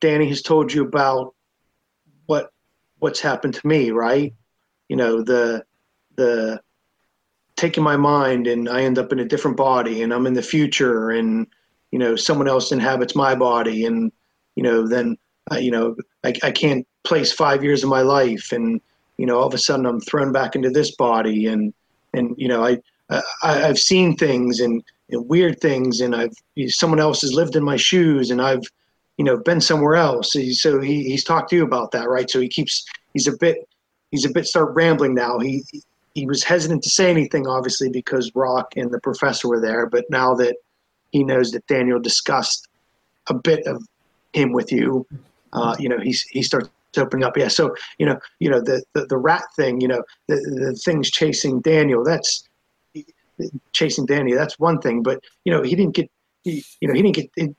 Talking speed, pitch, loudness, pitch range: 205 wpm, 130 Hz, -19 LUFS, 120-155 Hz